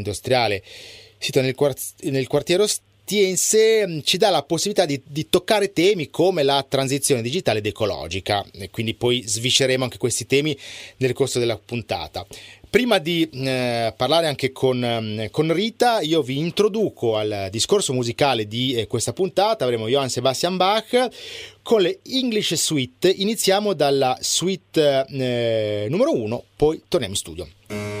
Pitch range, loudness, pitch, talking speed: 115-185 Hz, -21 LUFS, 135 Hz, 145 wpm